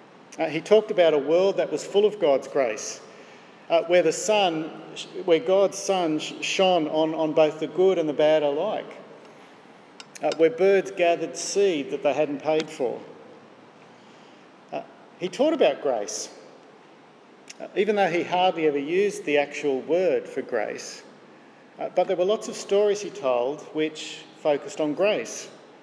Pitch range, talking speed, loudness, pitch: 155-195 Hz, 160 wpm, -24 LUFS, 170 Hz